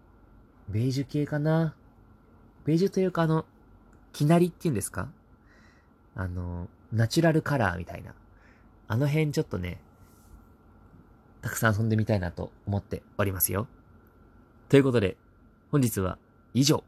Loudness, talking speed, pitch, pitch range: -27 LUFS, 290 characters per minute, 115 Hz, 95-135 Hz